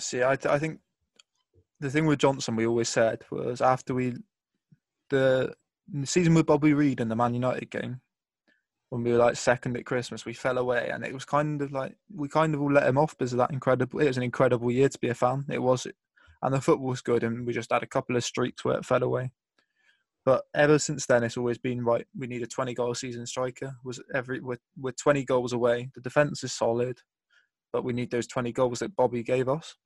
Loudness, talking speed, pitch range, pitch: -27 LUFS, 235 wpm, 120-140 Hz, 125 Hz